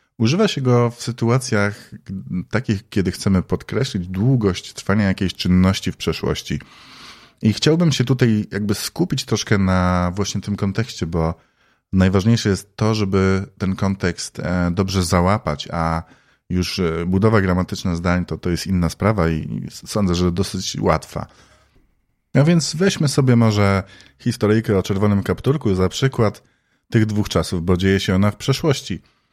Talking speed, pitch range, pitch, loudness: 145 wpm, 90-115 Hz, 100 Hz, -19 LUFS